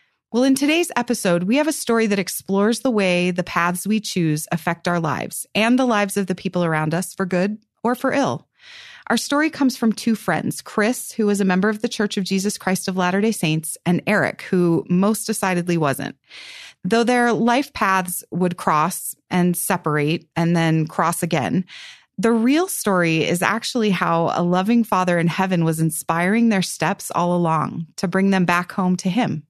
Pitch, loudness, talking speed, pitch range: 190 Hz, -20 LUFS, 195 wpm, 175-230 Hz